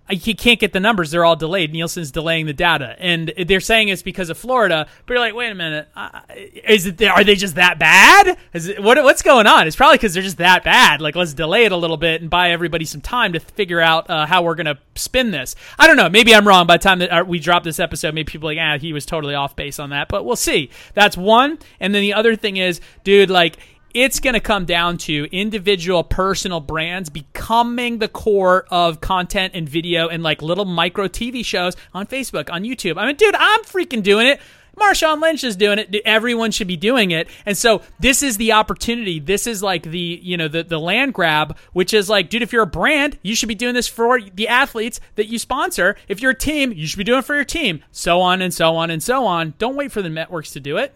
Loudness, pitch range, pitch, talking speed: -15 LUFS, 170-230 Hz, 195 Hz, 250 wpm